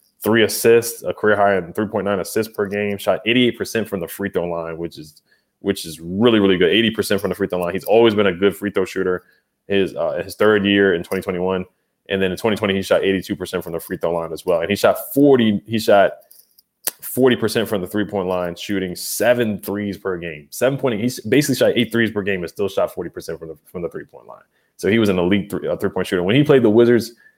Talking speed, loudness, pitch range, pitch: 270 wpm, -19 LUFS, 90-115 Hz, 100 Hz